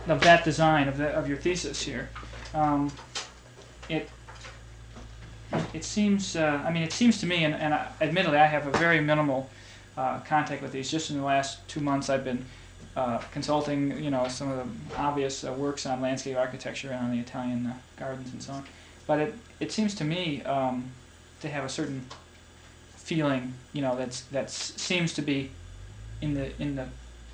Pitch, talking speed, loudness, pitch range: 135 Hz, 190 wpm, -28 LUFS, 125-150 Hz